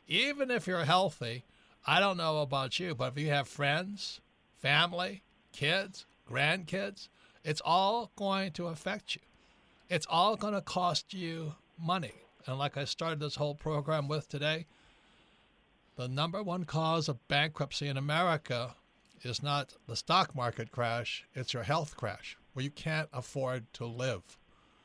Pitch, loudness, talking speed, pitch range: 155 Hz, -33 LUFS, 150 wpm, 135-180 Hz